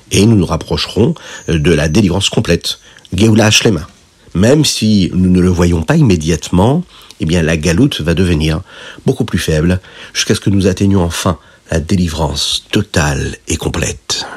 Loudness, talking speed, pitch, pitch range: -13 LUFS, 155 wpm, 90 Hz, 85-100 Hz